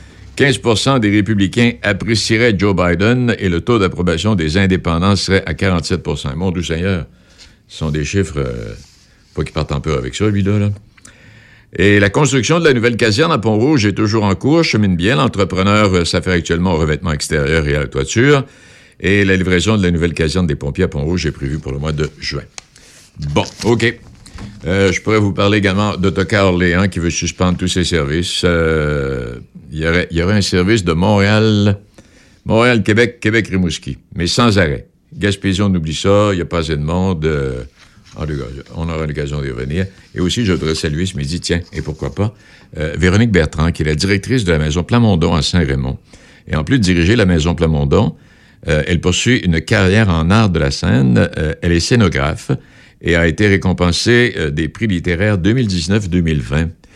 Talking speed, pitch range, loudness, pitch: 190 wpm, 80-105 Hz, -15 LUFS, 90 Hz